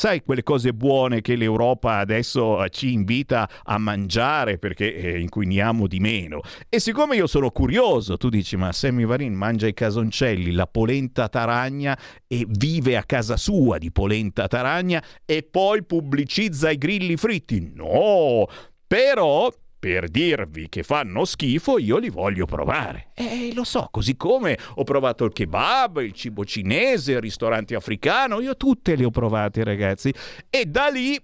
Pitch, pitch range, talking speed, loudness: 120 Hz, 105-150 Hz, 155 wpm, -22 LUFS